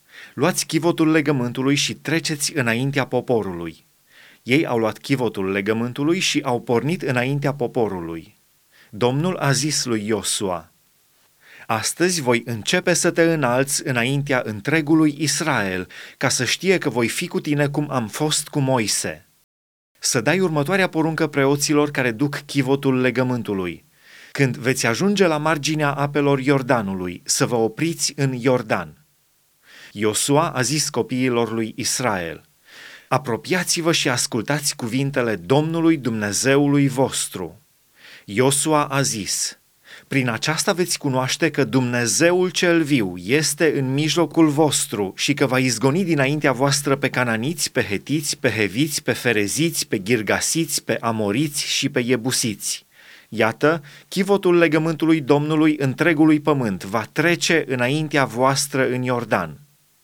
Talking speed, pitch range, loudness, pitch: 125 wpm, 120-155 Hz, -20 LUFS, 140 Hz